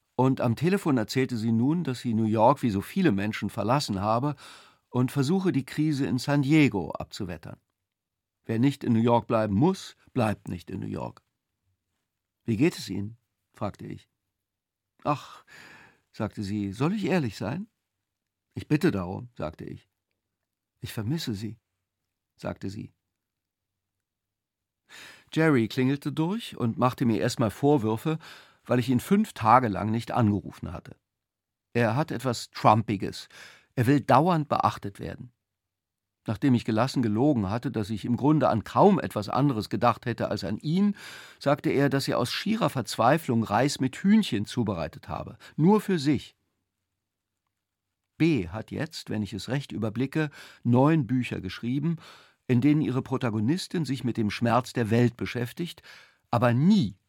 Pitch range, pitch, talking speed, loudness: 100-140 Hz, 115 Hz, 150 wpm, -26 LUFS